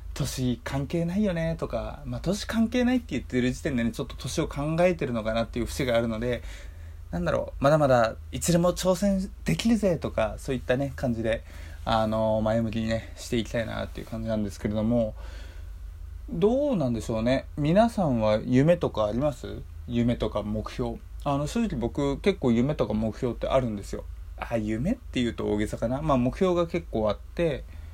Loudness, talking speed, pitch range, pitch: -27 LUFS, 375 characters per minute, 105-145 Hz, 115 Hz